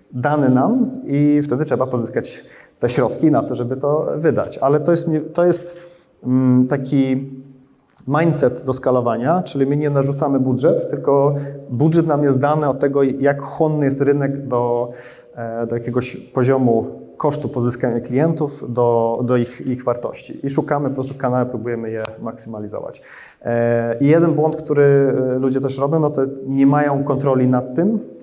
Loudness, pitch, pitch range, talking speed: -18 LUFS, 135 Hz, 125-145 Hz, 155 wpm